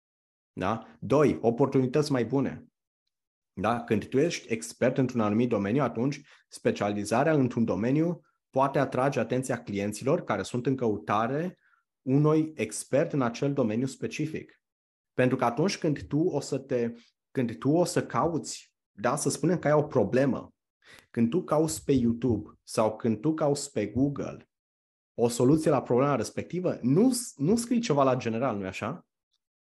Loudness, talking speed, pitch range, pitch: -28 LUFS, 150 wpm, 115-145 Hz, 130 Hz